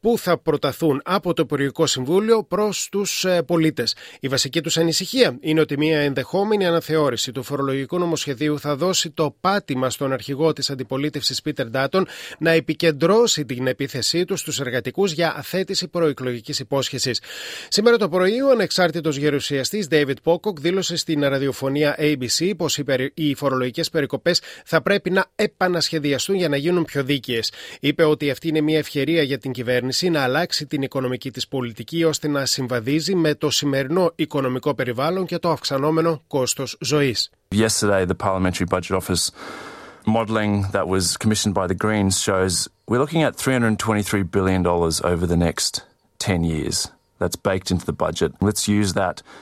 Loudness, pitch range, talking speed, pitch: -21 LUFS, 125-165 Hz, 115 wpm, 145 Hz